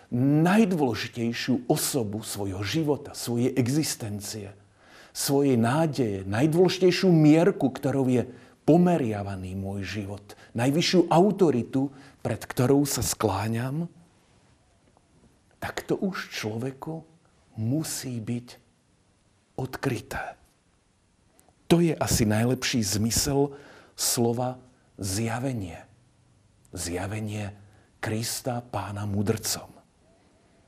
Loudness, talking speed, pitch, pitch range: -26 LUFS, 75 wpm, 120 Hz, 105-140 Hz